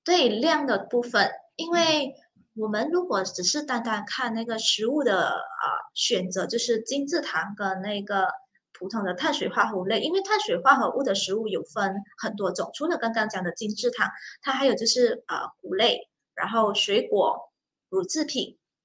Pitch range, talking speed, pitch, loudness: 205-305 Hz, 260 characters per minute, 230 Hz, -25 LUFS